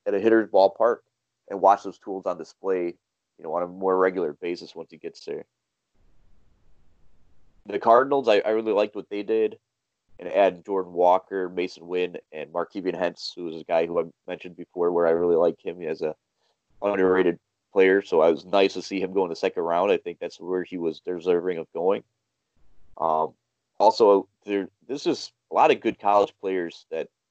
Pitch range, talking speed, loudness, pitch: 90-100 Hz, 195 wpm, -24 LUFS, 95 Hz